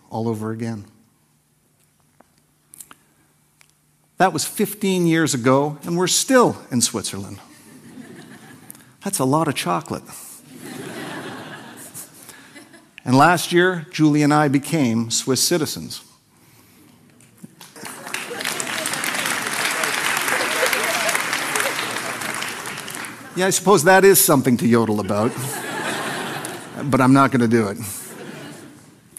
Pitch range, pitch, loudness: 115-170 Hz, 135 Hz, -19 LUFS